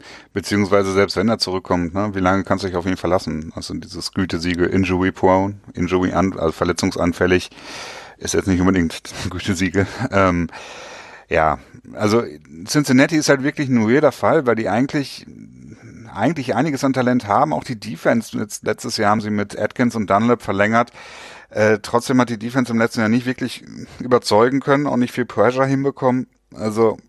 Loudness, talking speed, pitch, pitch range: -19 LUFS, 170 wpm, 105 Hz, 95-125 Hz